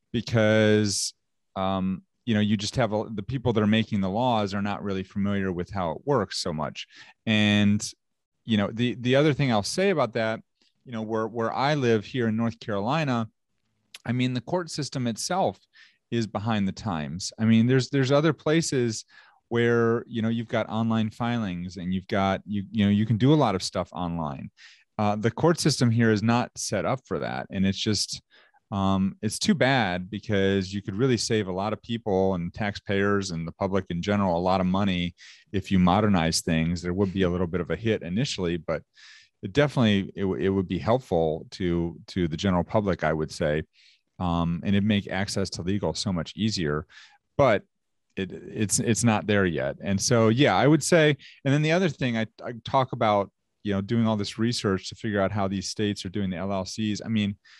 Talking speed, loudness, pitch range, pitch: 210 wpm, -26 LUFS, 95-115 Hz, 105 Hz